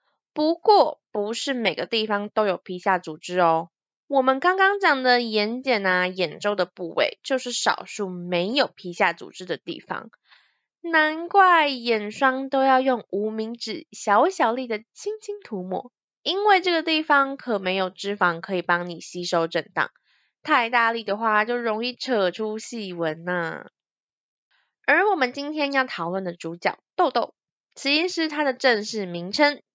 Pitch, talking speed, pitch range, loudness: 225 Hz, 235 characters per minute, 185-280 Hz, -23 LUFS